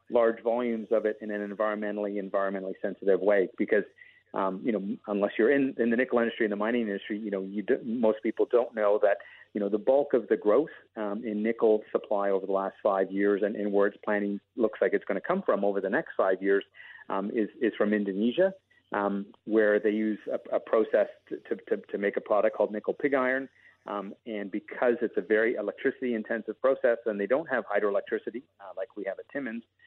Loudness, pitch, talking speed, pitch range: -28 LUFS, 105 Hz, 220 wpm, 100-115 Hz